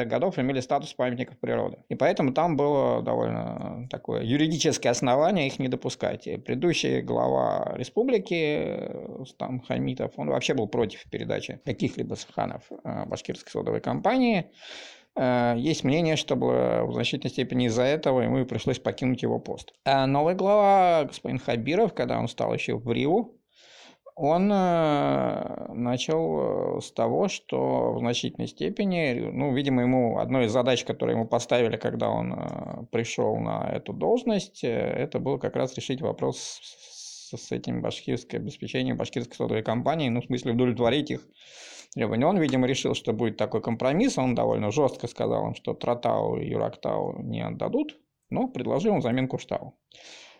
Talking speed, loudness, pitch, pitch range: 145 wpm, -27 LUFS, 130 Hz, 120-155 Hz